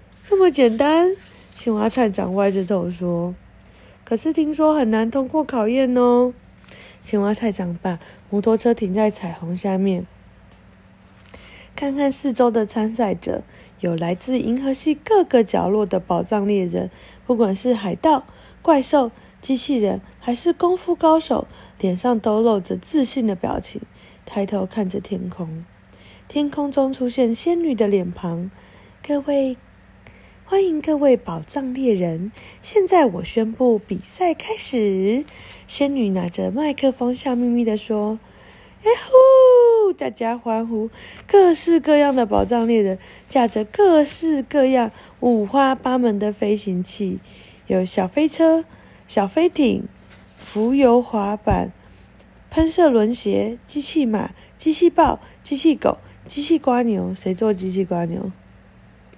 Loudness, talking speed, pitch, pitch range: -19 LUFS, 200 characters per minute, 235 Hz, 200-290 Hz